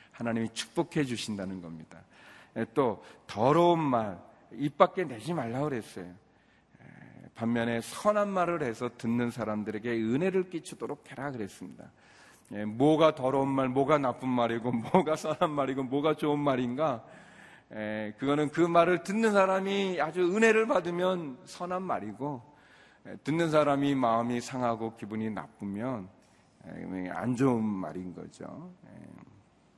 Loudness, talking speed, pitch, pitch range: -30 LUFS, 270 characters per minute, 135 Hz, 115-170 Hz